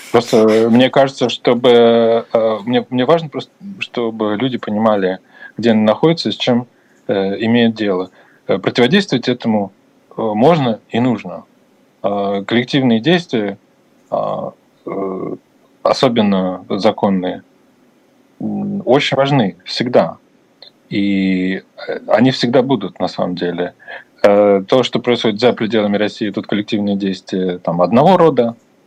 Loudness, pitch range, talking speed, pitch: -15 LUFS, 100-125 Hz, 110 wpm, 115 Hz